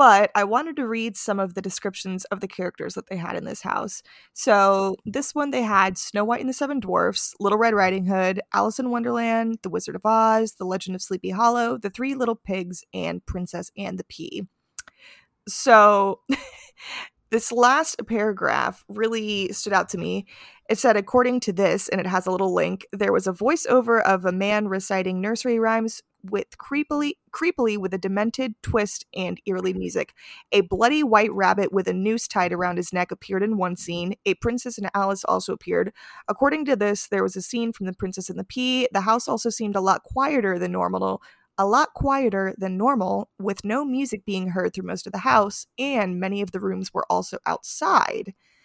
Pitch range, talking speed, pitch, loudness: 190-235 Hz, 195 wpm, 205 Hz, -23 LUFS